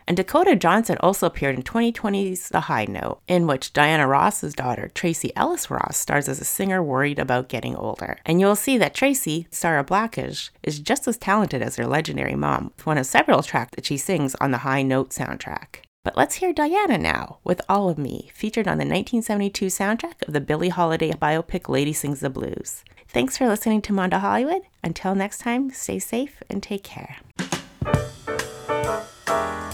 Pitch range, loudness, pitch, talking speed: 145-215 Hz, -23 LUFS, 185 Hz, 185 wpm